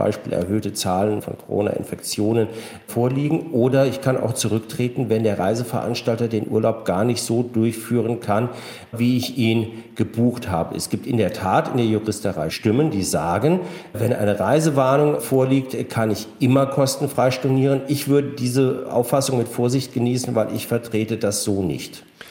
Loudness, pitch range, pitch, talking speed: -21 LUFS, 110-130 Hz, 120 Hz, 160 wpm